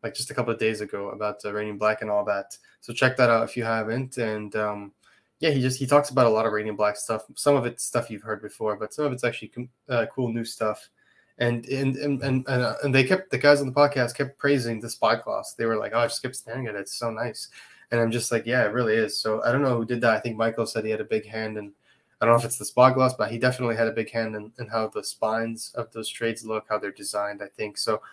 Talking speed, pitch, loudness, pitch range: 295 wpm, 115 Hz, -25 LUFS, 110-130 Hz